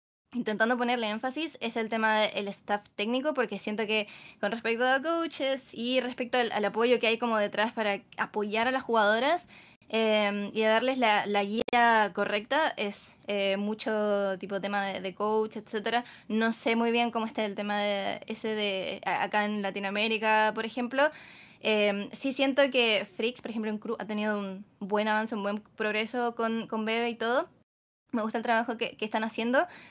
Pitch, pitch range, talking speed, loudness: 220 Hz, 205-235 Hz, 185 wpm, -29 LUFS